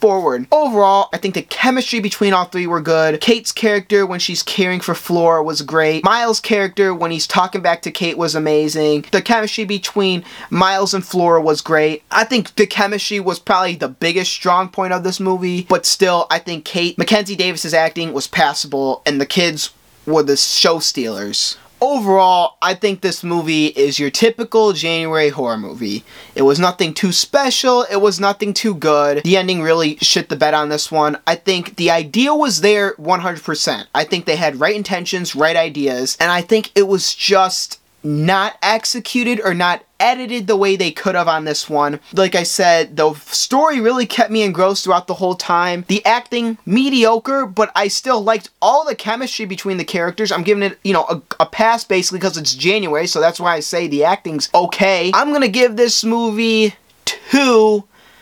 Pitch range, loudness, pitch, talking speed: 165-215 Hz, -15 LUFS, 185 Hz, 190 wpm